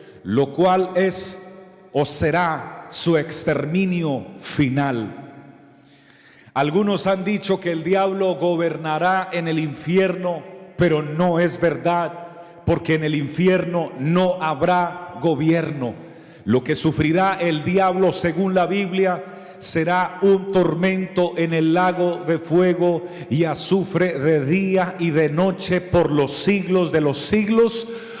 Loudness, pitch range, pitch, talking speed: -20 LUFS, 160-185 Hz, 175 Hz, 125 wpm